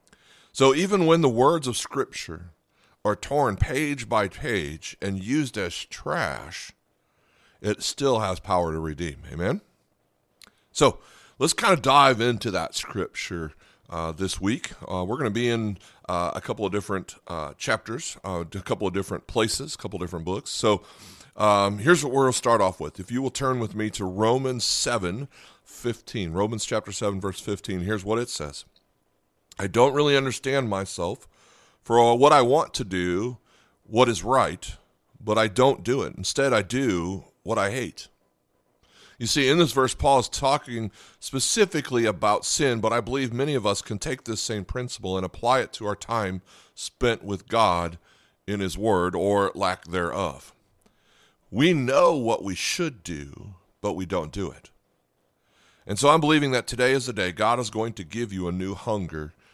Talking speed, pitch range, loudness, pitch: 180 wpm, 95-125 Hz, -24 LUFS, 110 Hz